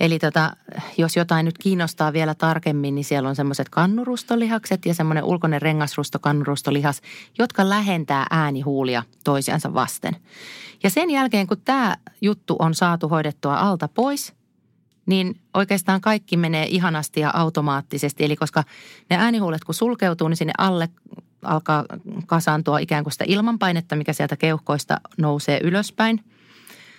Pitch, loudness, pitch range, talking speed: 165 Hz, -21 LUFS, 150-195 Hz, 135 wpm